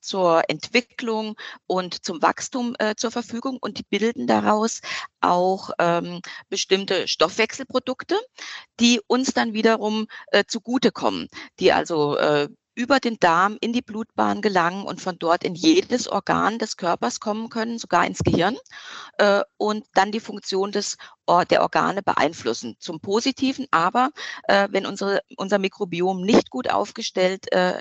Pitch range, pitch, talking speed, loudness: 185-240 Hz, 215 Hz, 145 wpm, -22 LUFS